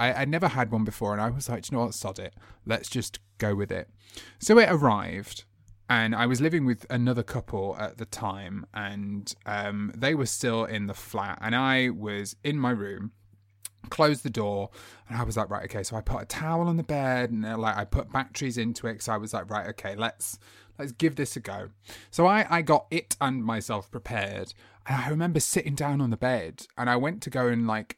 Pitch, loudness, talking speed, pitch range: 115 Hz, -28 LUFS, 225 wpm, 105-130 Hz